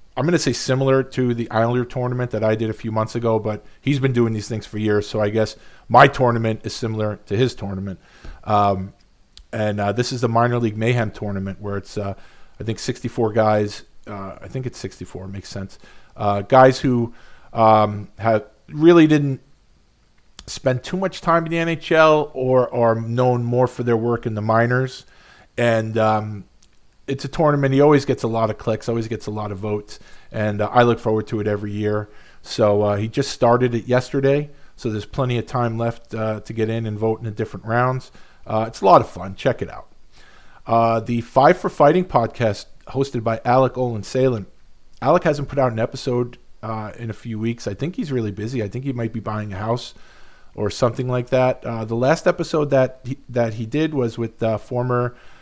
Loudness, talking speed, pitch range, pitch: -20 LUFS, 210 wpm, 105-130 Hz, 115 Hz